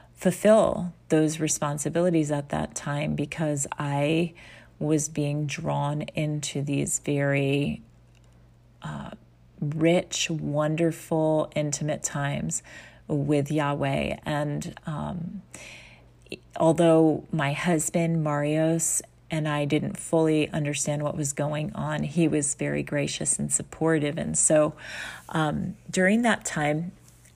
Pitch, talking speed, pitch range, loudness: 150 Hz, 105 wpm, 145-160 Hz, -26 LUFS